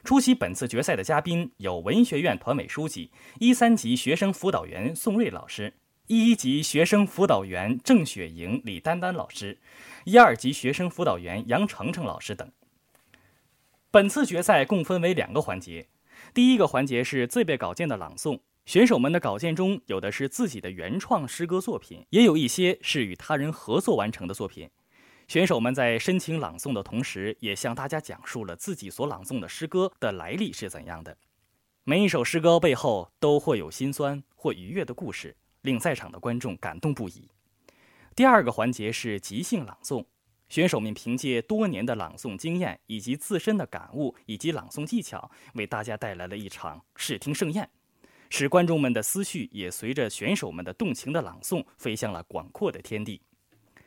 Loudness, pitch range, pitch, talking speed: -26 LUFS, 115-185 Hz, 145 Hz, 280 characters per minute